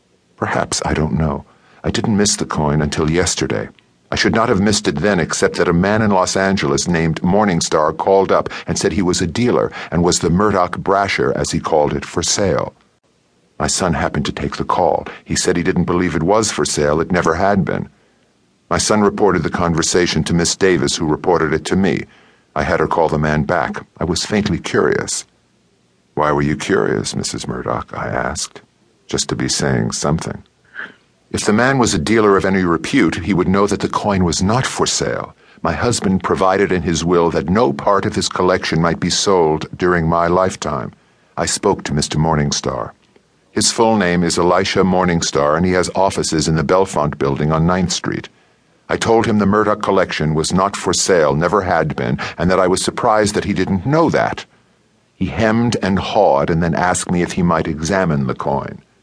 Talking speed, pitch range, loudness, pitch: 200 wpm, 80-95 Hz, -16 LUFS, 90 Hz